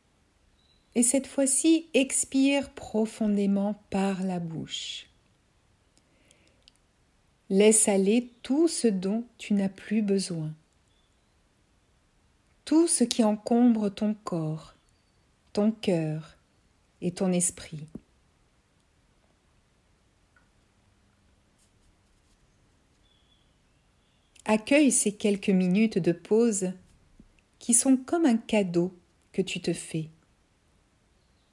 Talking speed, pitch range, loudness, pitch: 80 wpm, 180-235 Hz, -26 LUFS, 210 Hz